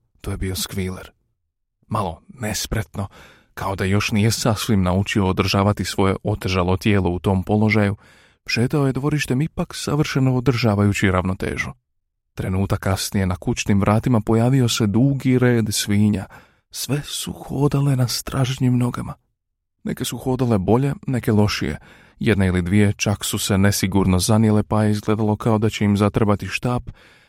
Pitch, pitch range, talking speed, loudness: 105 Hz, 100-120 Hz, 145 wpm, -20 LUFS